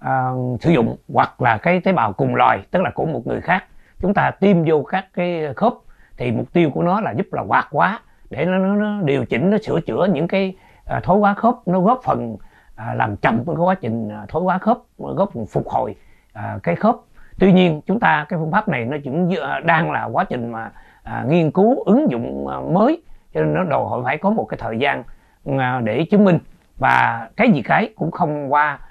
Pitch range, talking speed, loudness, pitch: 130-190 Hz, 215 wpm, -19 LUFS, 170 Hz